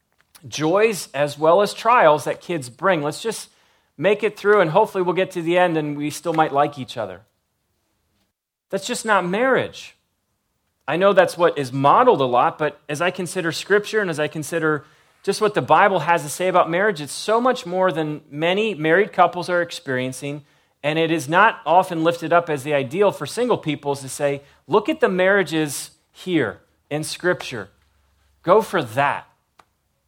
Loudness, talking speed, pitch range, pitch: -20 LUFS, 185 wpm, 145-185 Hz, 165 Hz